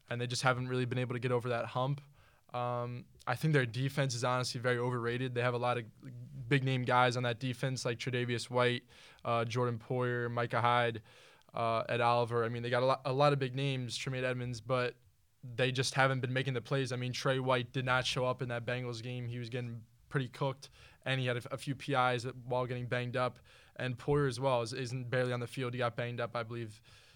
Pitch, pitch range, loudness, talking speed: 125 Hz, 120-130 Hz, -34 LUFS, 240 wpm